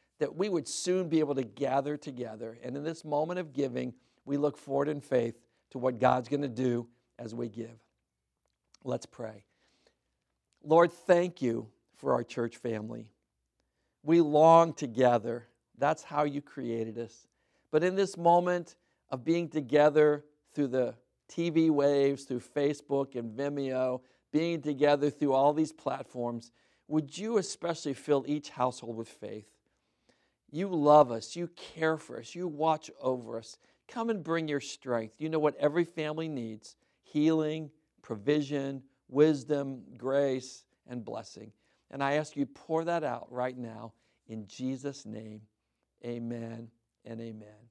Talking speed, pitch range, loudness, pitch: 145 wpm, 120-155 Hz, -30 LUFS, 140 Hz